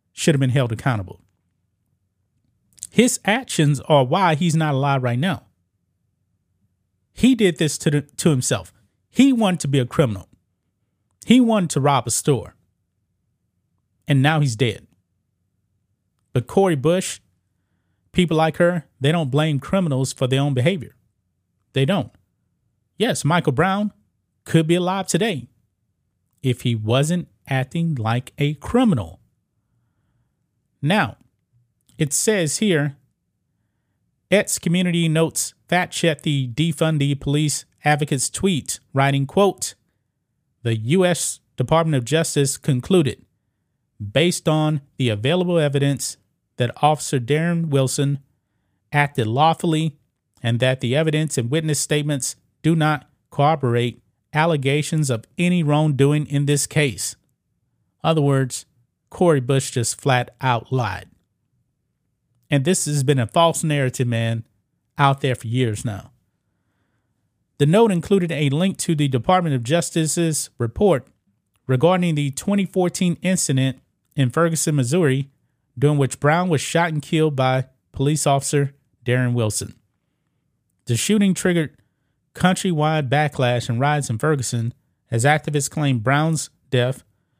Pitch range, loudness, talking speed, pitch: 115-155 Hz, -20 LUFS, 125 wpm, 140 Hz